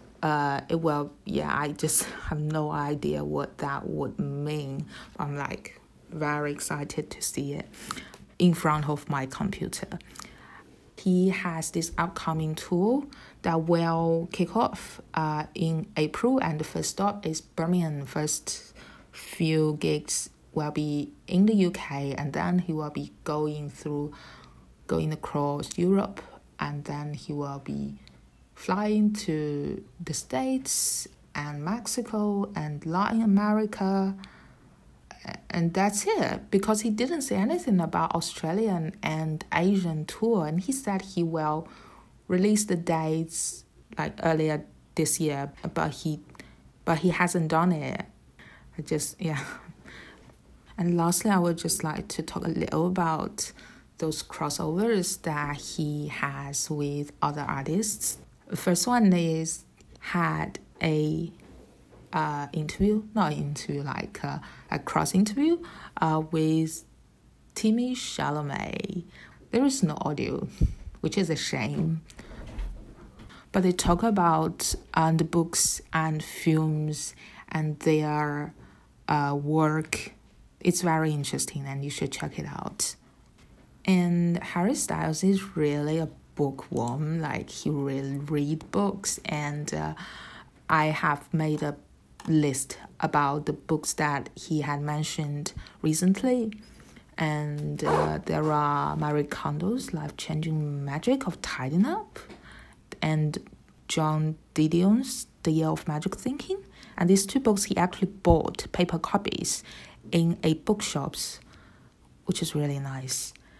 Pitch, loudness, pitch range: 160 Hz, -28 LUFS, 150-185 Hz